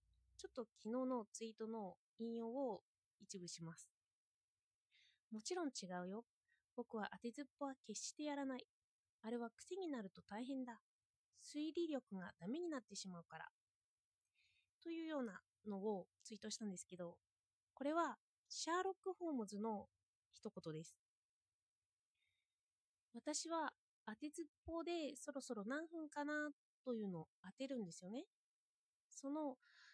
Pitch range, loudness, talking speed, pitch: 180-290 Hz, -49 LUFS, 275 characters per minute, 225 Hz